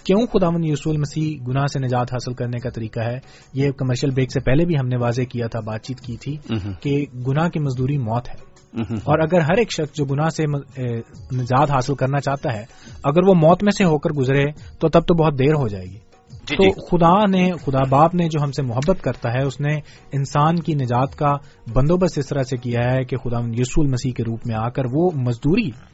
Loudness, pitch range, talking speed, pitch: -20 LUFS, 125-155 Hz, 225 wpm, 140 Hz